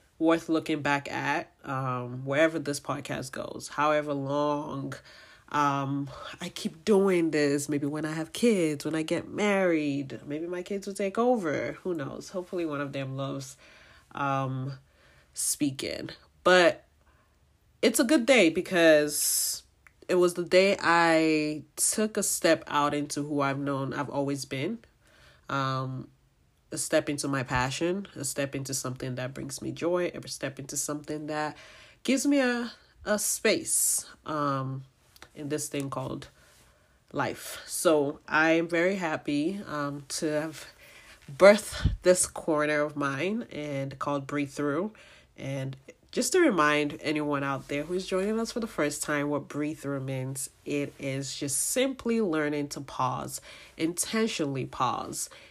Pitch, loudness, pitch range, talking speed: 150 Hz, -28 LUFS, 140-175 Hz, 145 wpm